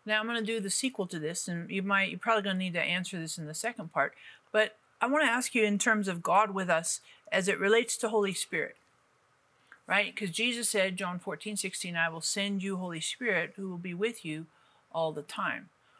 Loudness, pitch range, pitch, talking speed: -30 LUFS, 180-220 Hz, 195 Hz, 230 wpm